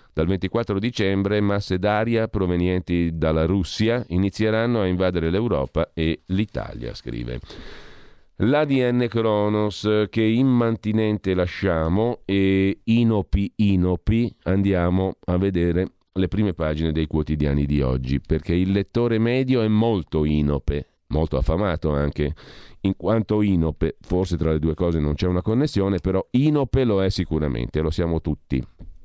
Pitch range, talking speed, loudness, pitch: 80-105 Hz, 130 wpm, -22 LUFS, 95 Hz